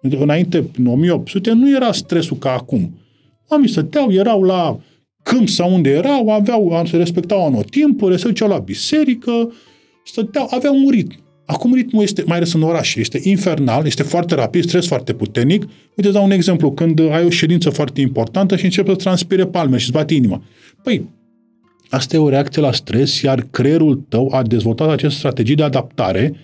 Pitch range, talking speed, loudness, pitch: 140-200 Hz, 180 wpm, -15 LUFS, 170 Hz